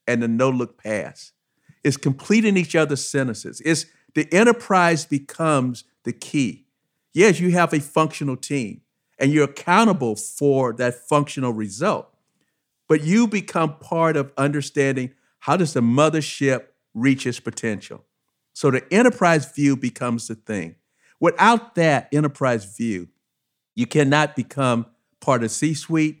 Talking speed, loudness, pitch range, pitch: 135 wpm, -20 LUFS, 125-160 Hz, 140 Hz